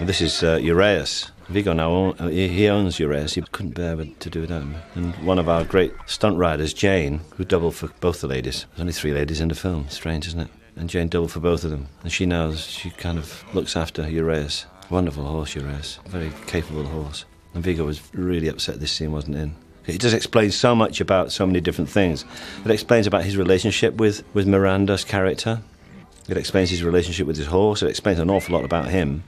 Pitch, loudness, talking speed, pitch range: 85 Hz, -22 LUFS, 215 wpm, 80-95 Hz